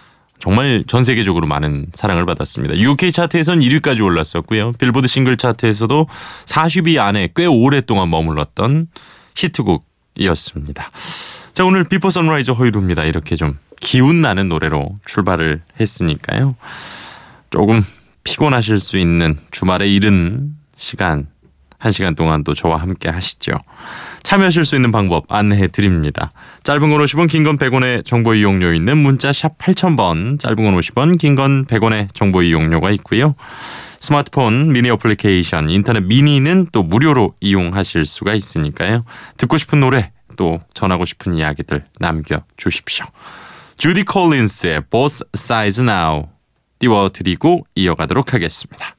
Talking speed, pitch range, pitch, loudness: 325 characters per minute, 85-140 Hz, 110 Hz, -15 LUFS